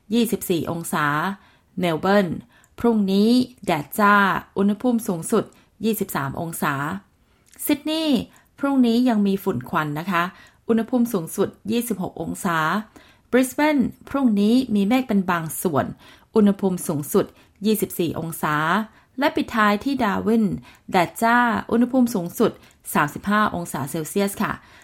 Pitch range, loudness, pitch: 175-235 Hz, -22 LUFS, 205 Hz